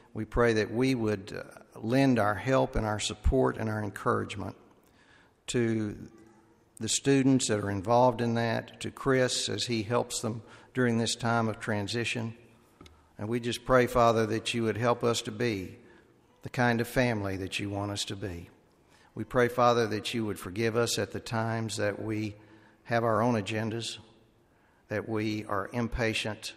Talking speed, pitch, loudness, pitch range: 170 wpm, 115 Hz, -29 LUFS, 105-120 Hz